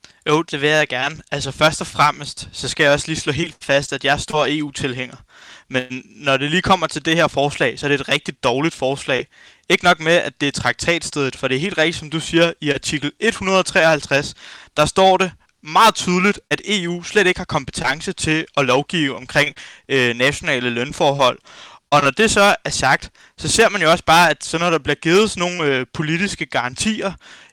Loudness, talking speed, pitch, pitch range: -17 LUFS, 210 wpm, 155 Hz, 140-175 Hz